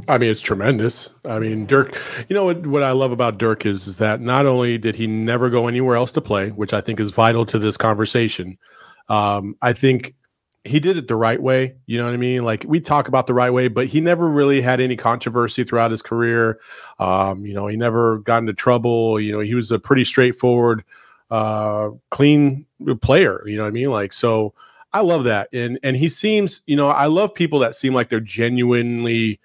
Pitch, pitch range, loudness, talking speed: 120 Hz, 110-130 Hz, -18 LUFS, 220 wpm